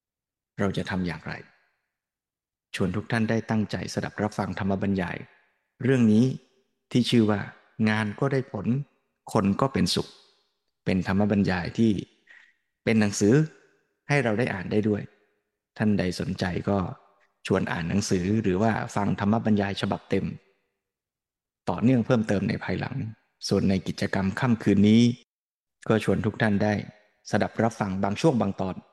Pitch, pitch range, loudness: 105 Hz, 95-115 Hz, -26 LUFS